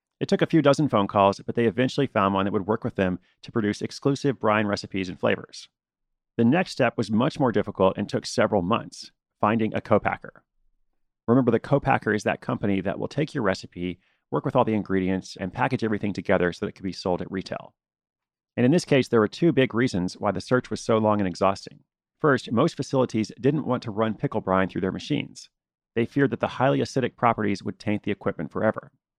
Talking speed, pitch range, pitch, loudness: 220 wpm, 95-125 Hz, 110 Hz, -25 LUFS